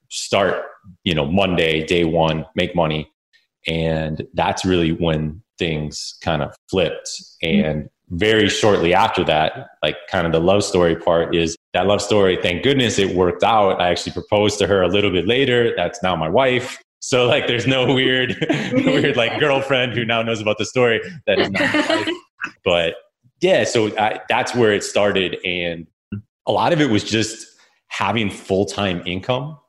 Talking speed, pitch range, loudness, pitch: 170 wpm, 85-120 Hz, -18 LUFS, 100 Hz